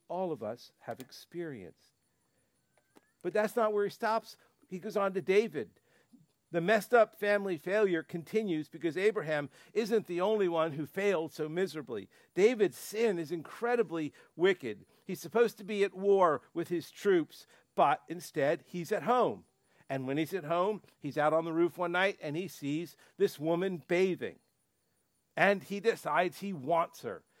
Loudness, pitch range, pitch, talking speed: -32 LUFS, 165-210 Hz, 185 Hz, 165 wpm